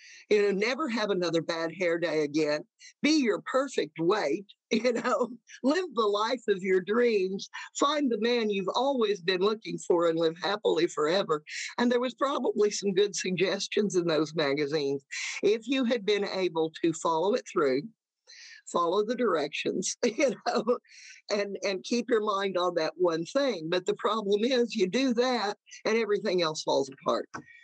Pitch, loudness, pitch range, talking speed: 210 Hz, -28 LUFS, 185-255 Hz, 170 wpm